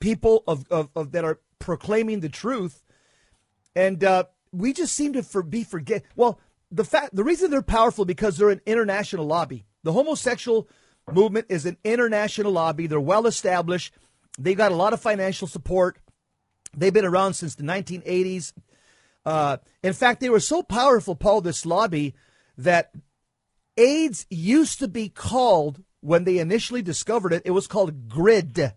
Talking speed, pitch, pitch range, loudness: 165 wpm, 185 Hz, 165-220 Hz, -23 LUFS